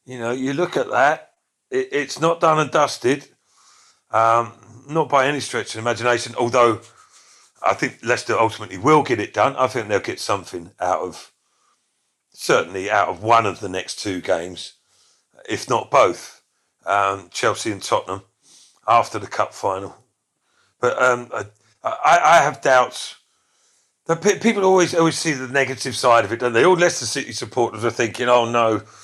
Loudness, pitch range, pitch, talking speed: -19 LUFS, 115-155 Hz, 125 Hz, 170 wpm